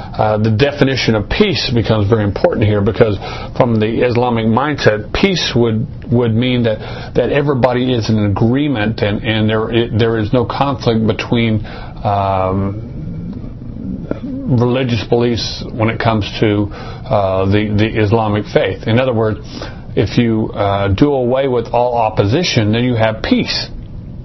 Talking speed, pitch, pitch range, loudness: 150 wpm, 115 Hz, 110-125 Hz, -15 LUFS